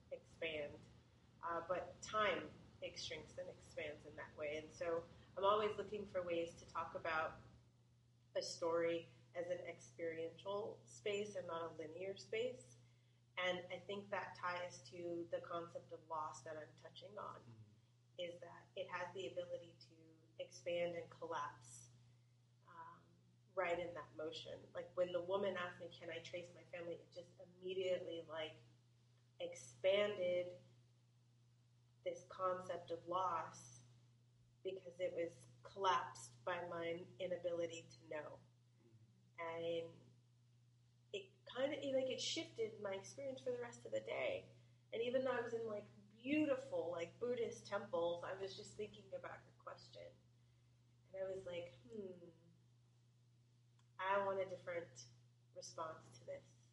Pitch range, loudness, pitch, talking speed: 120-185 Hz, -46 LUFS, 170 Hz, 140 wpm